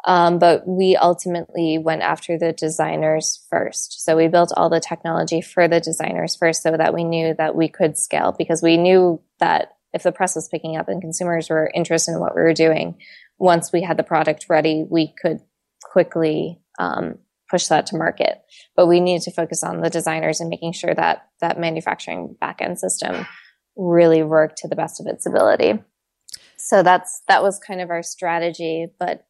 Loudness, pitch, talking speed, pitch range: -19 LUFS, 165 Hz, 190 wpm, 160-175 Hz